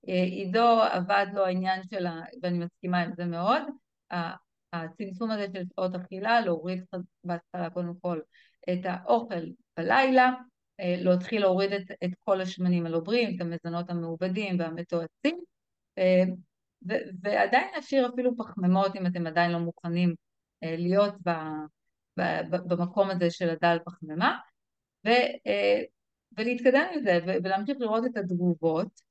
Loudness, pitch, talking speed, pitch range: -28 LUFS, 185 Hz, 120 wpm, 175-205 Hz